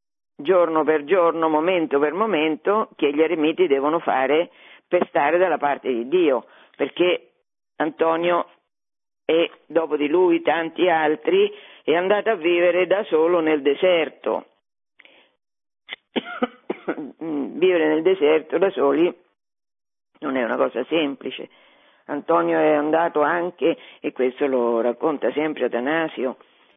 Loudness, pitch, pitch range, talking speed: -21 LUFS, 165 Hz, 155-205 Hz, 120 wpm